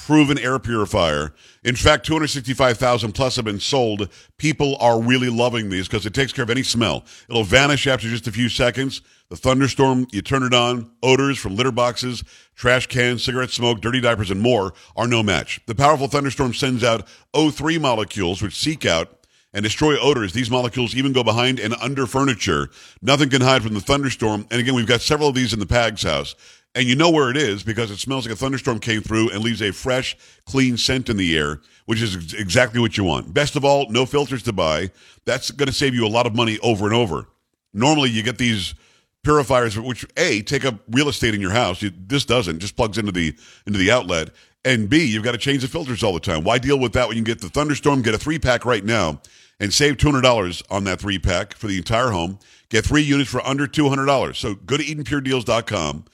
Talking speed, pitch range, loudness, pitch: 220 wpm, 105-135 Hz, -19 LUFS, 120 Hz